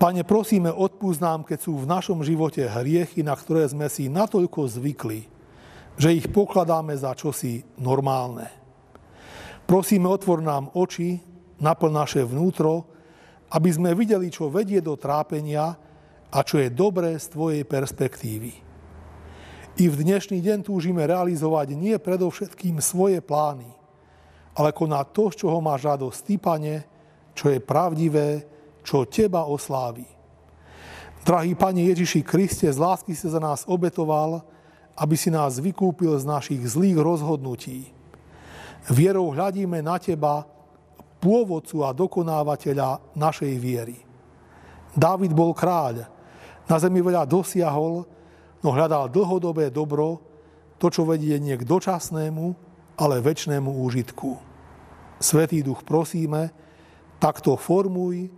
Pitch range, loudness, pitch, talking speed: 140-175 Hz, -23 LUFS, 160 Hz, 120 wpm